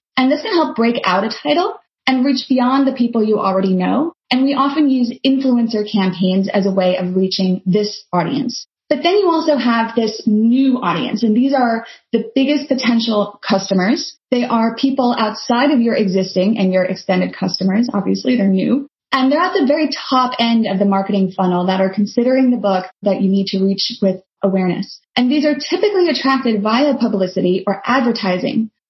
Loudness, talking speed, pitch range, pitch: -16 LUFS, 185 wpm, 195-265 Hz, 230 Hz